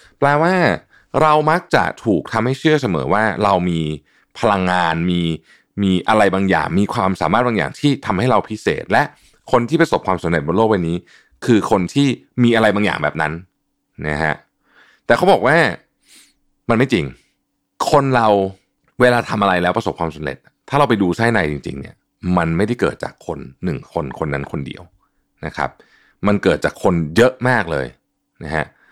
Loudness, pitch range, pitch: -17 LUFS, 85-125 Hz, 95 Hz